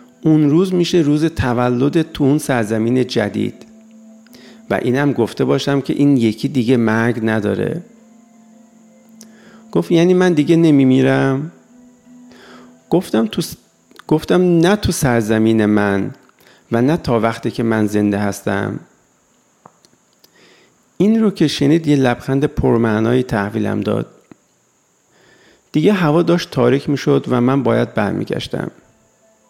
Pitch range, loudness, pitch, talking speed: 115-175 Hz, -16 LUFS, 140 Hz, 115 wpm